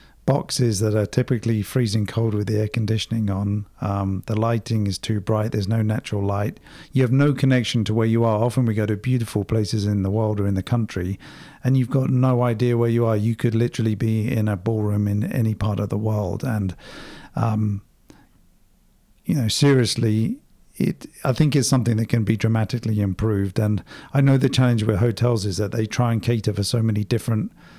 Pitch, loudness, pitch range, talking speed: 110 Hz, -22 LUFS, 105-120 Hz, 205 wpm